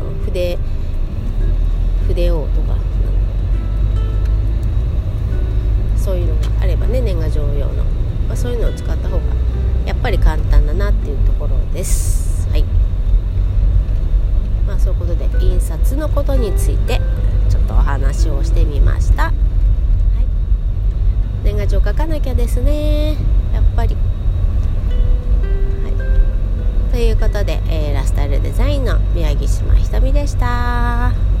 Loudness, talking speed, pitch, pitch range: -18 LUFS, 240 characters per minute, 95 Hz, 85-100 Hz